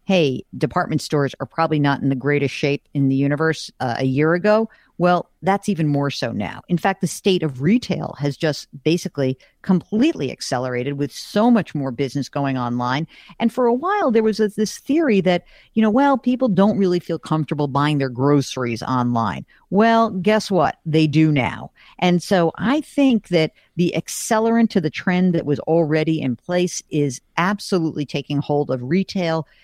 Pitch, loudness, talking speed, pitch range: 160 Hz, -20 LUFS, 180 wpm, 145-195 Hz